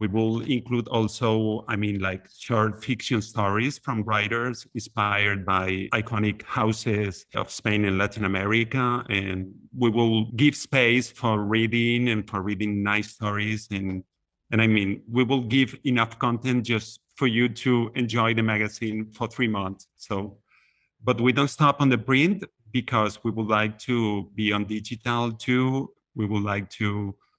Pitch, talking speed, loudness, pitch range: 110 Hz, 160 wpm, -25 LUFS, 105-120 Hz